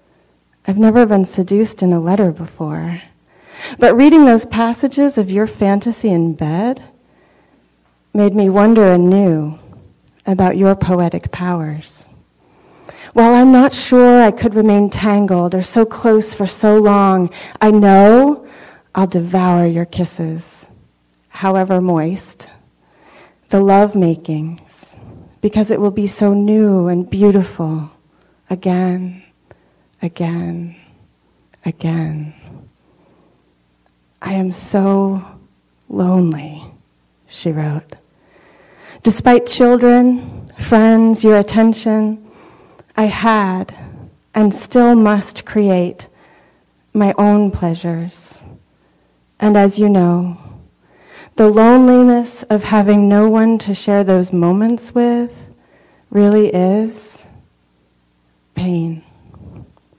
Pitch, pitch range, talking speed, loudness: 195 Hz, 170-215 Hz, 100 wpm, -13 LUFS